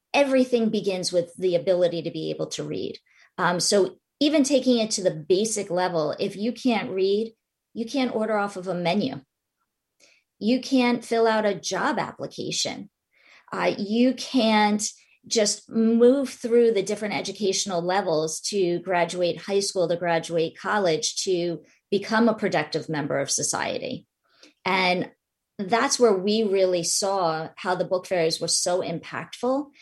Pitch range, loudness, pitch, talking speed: 175-230 Hz, -24 LUFS, 200 Hz, 150 wpm